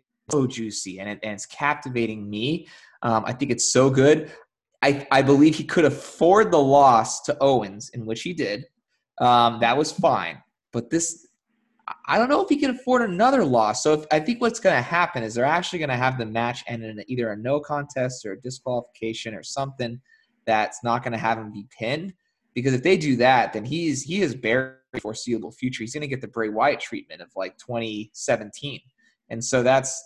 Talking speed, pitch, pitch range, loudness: 210 wpm, 130 Hz, 115-155 Hz, -22 LUFS